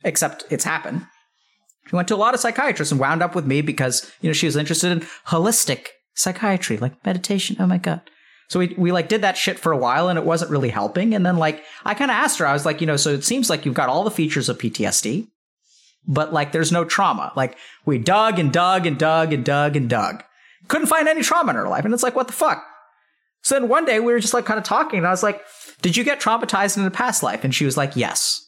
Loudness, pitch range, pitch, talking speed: -20 LUFS, 150-220 Hz, 180 Hz, 265 wpm